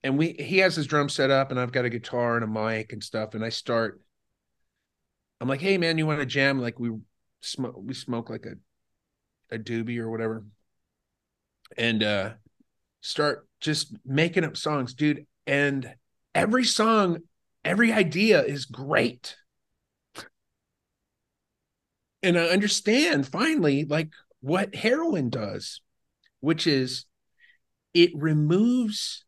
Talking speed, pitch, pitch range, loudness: 135 wpm, 140 Hz, 115-170 Hz, -25 LUFS